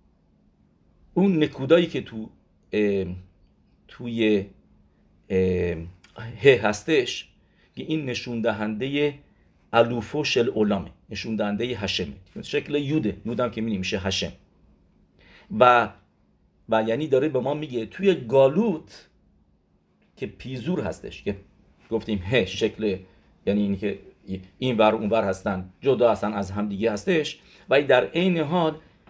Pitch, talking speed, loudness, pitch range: 110 Hz, 120 wpm, -24 LUFS, 100-135 Hz